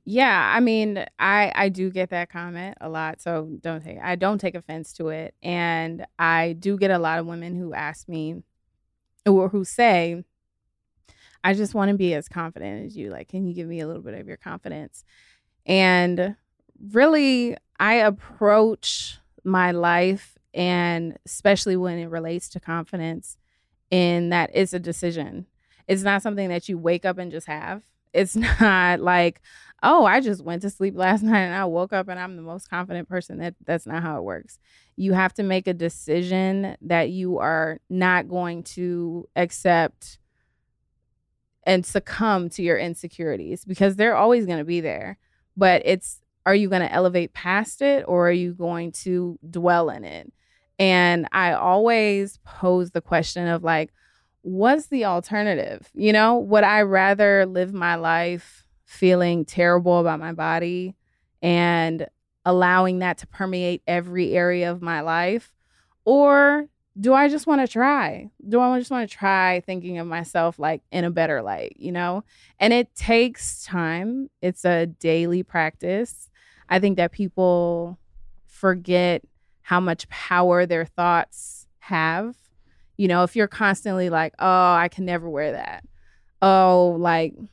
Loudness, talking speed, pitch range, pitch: -21 LUFS, 165 wpm, 170-195 Hz, 180 Hz